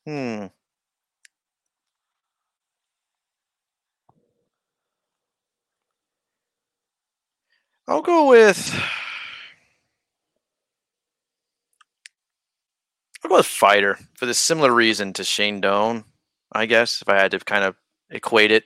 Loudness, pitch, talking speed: -18 LUFS, 110 Hz, 80 wpm